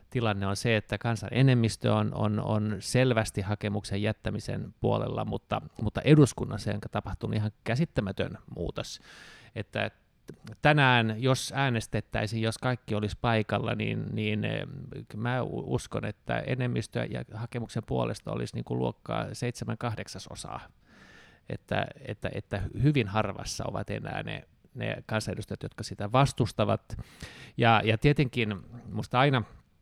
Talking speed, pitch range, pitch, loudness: 125 wpm, 105-125 Hz, 115 Hz, -29 LUFS